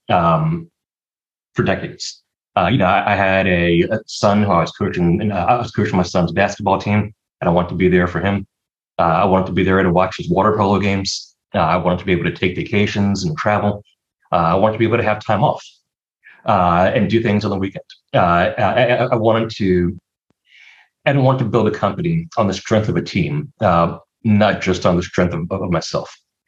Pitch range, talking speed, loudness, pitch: 95-110 Hz, 225 wpm, -17 LUFS, 100 Hz